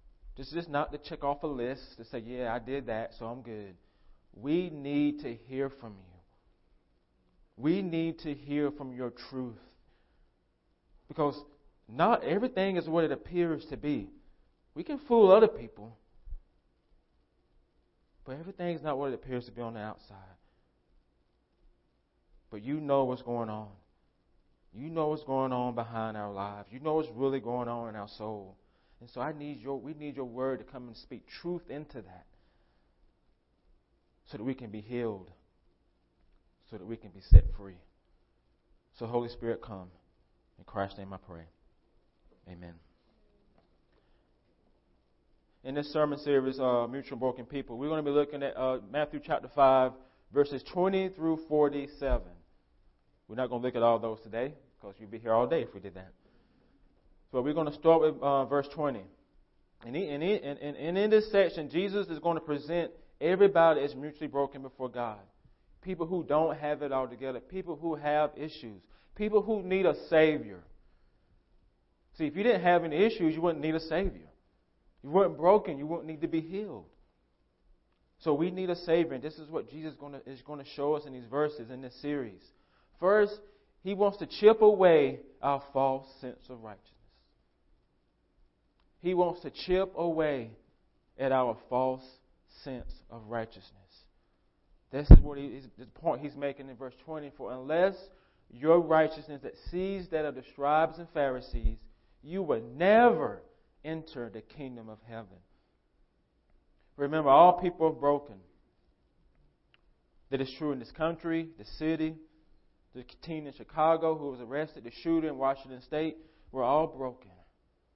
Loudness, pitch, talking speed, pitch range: -30 LUFS, 135 Hz, 170 wpm, 110-155 Hz